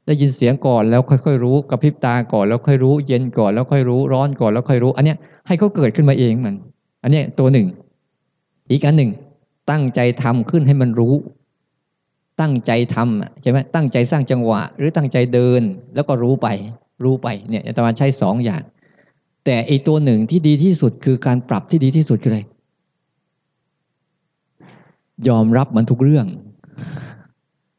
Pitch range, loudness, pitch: 120-150 Hz, -16 LUFS, 135 Hz